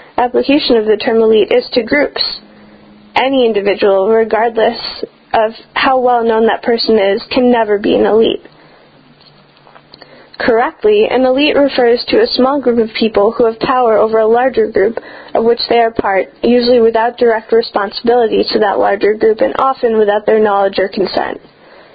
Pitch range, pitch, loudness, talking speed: 220-260 Hz, 235 Hz, -12 LUFS, 165 wpm